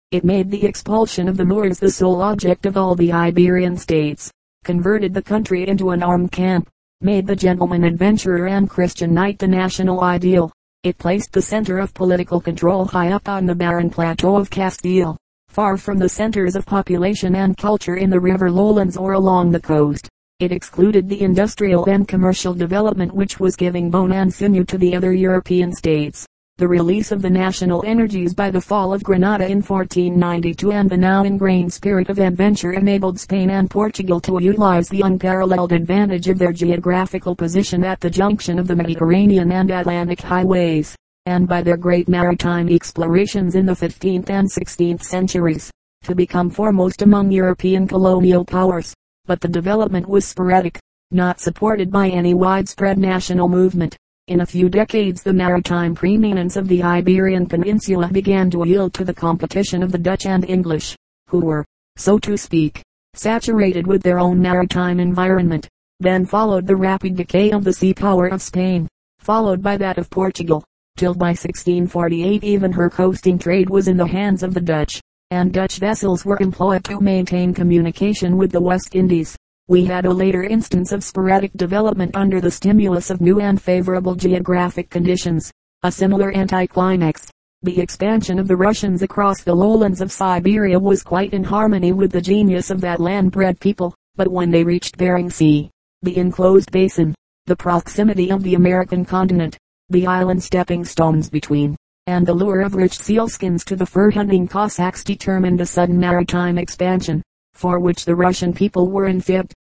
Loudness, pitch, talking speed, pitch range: -17 LUFS, 185 Hz, 170 wpm, 175-195 Hz